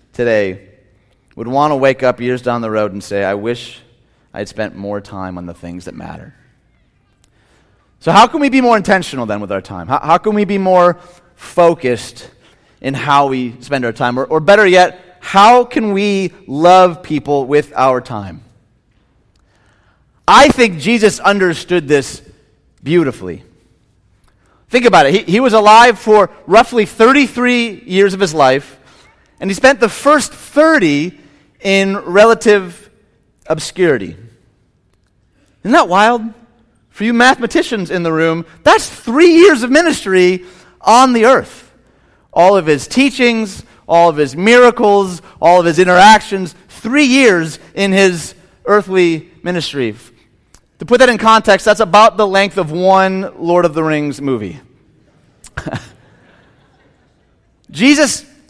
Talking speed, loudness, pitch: 145 wpm, -11 LUFS, 175 Hz